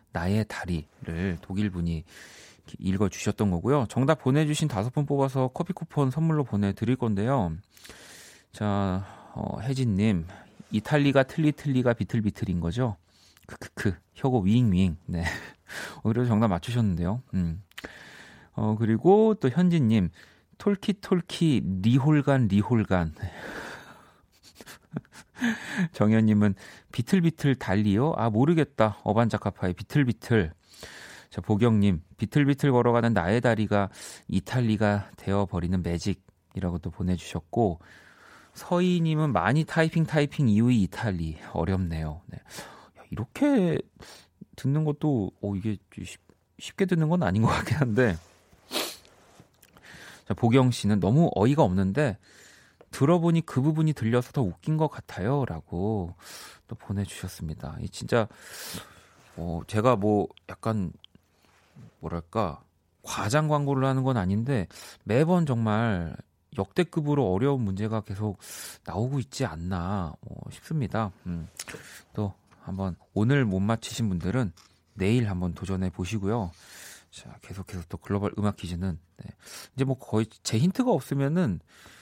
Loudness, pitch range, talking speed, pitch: -27 LUFS, 95-135 Hz, 260 characters per minute, 105 Hz